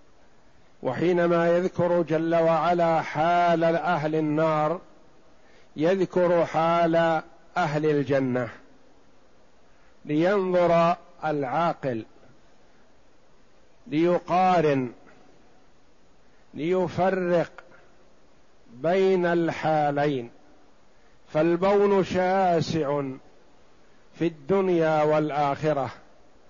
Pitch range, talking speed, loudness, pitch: 150-175 Hz, 50 wpm, -24 LUFS, 165 Hz